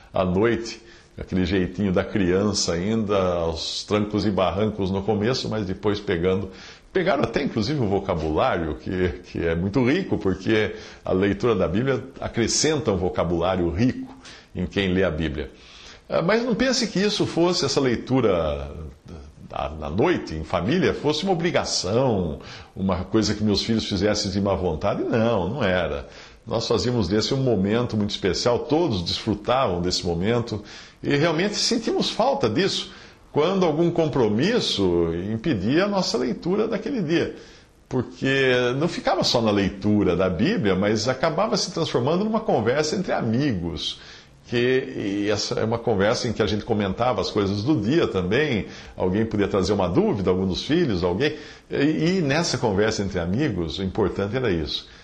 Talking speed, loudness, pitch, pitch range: 155 wpm, -23 LUFS, 105 Hz, 95-125 Hz